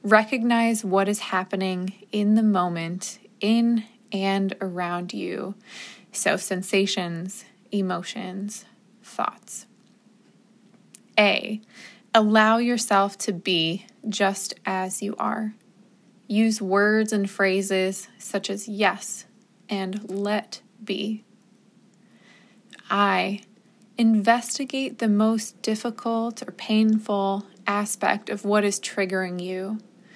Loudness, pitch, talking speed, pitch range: -24 LUFS, 210 Hz, 95 wpm, 195-220 Hz